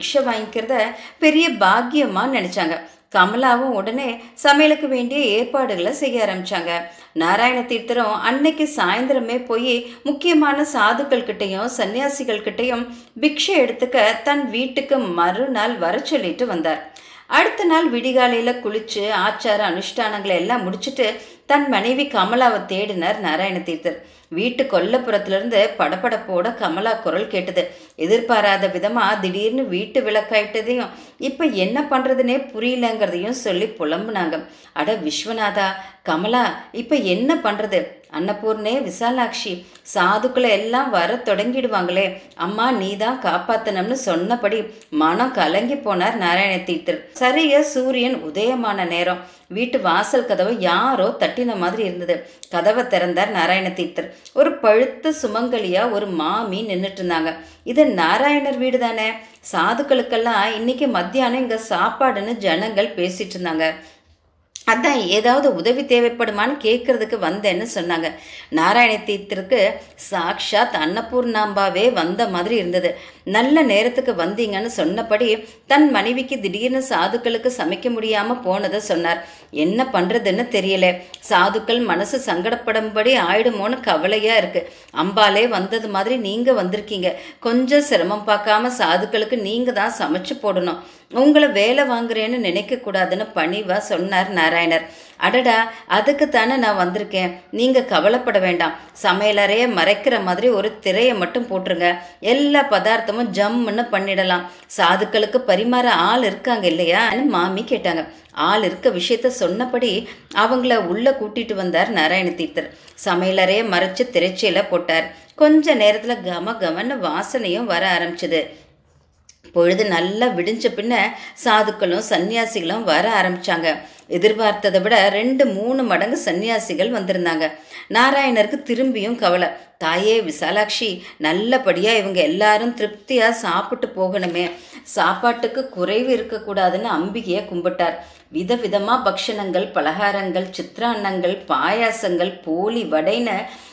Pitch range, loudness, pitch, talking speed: 185-250 Hz, -18 LUFS, 215 Hz, 100 wpm